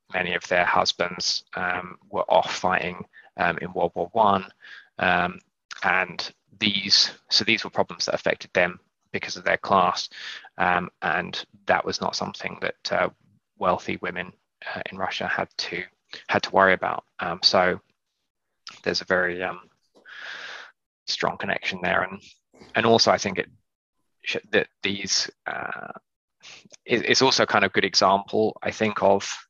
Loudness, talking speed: -24 LUFS, 155 wpm